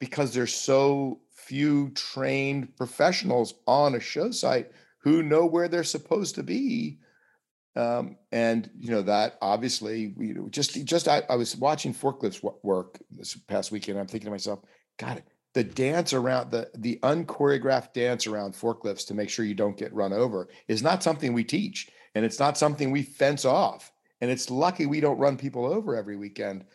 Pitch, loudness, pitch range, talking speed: 130 Hz, -27 LUFS, 110-145 Hz, 185 wpm